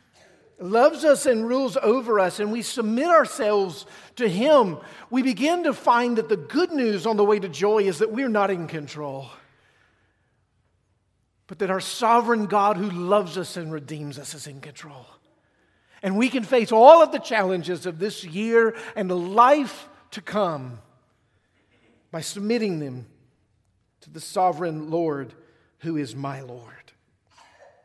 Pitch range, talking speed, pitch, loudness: 140-225 Hz, 155 wpm, 190 Hz, -22 LUFS